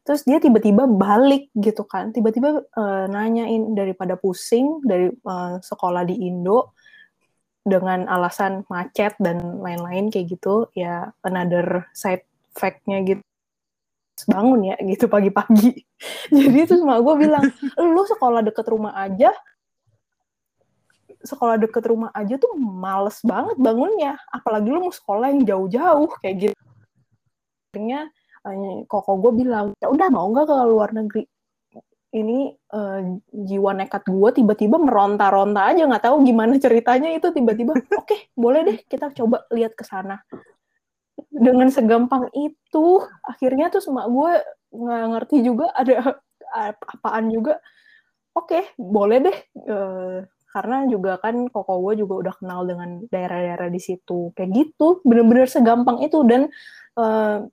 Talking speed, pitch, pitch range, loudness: 135 wpm, 225 Hz, 195-270 Hz, -19 LUFS